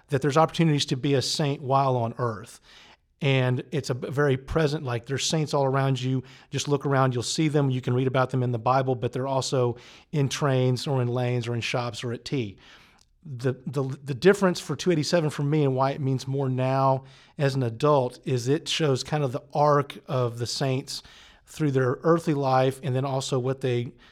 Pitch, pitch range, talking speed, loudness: 135 Hz, 130-145 Hz, 210 wpm, -25 LUFS